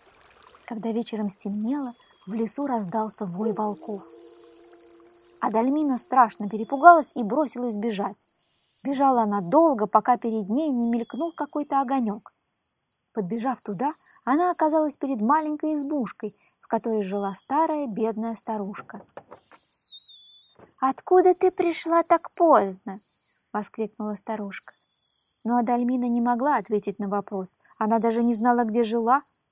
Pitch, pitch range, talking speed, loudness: 235 Hz, 210-280 Hz, 115 wpm, -24 LUFS